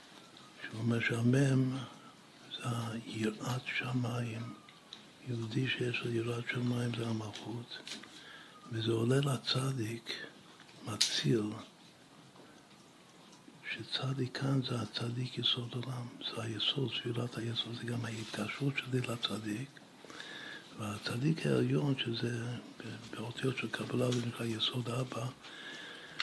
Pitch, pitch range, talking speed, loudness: 120 Hz, 115-125 Hz, 95 wpm, -36 LUFS